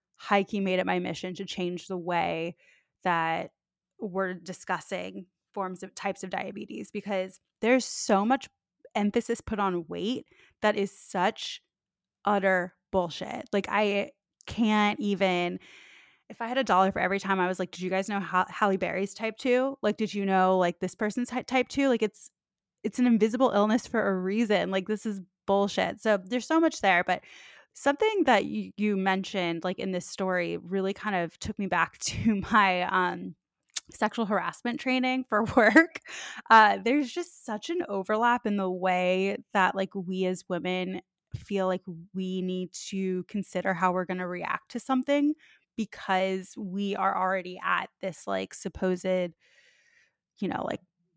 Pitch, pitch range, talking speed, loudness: 195 Hz, 185-220 Hz, 170 wpm, -28 LUFS